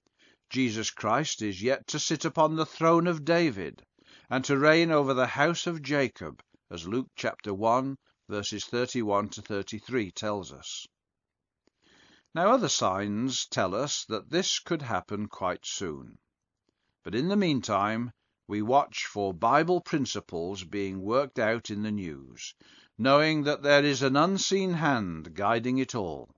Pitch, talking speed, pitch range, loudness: 125 Hz, 150 wpm, 100-150 Hz, -28 LUFS